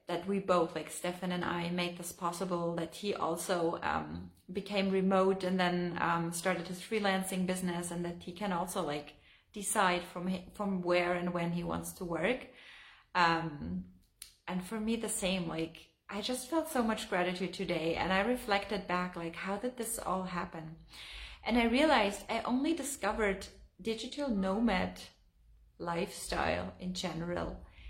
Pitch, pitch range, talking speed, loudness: 180 Hz, 170-200 Hz, 160 wpm, -34 LUFS